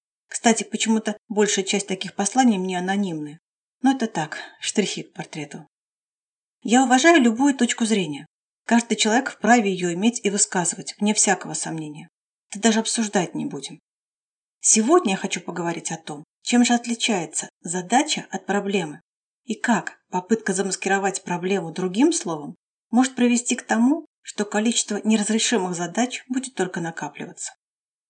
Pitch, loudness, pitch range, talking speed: 210 Hz, -22 LUFS, 185-235 Hz, 135 wpm